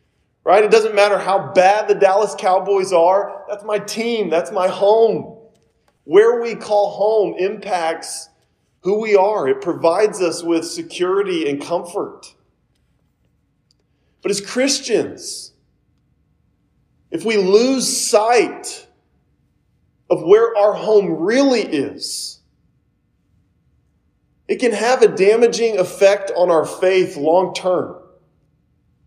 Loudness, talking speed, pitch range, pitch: -16 LUFS, 115 wpm, 185-225 Hz, 205 Hz